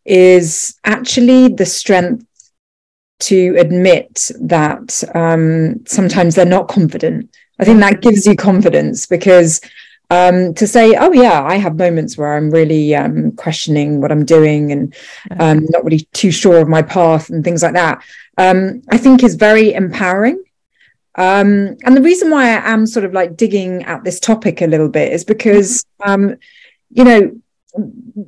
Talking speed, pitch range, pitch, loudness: 160 wpm, 165-220 Hz, 185 Hz, -11 LUFS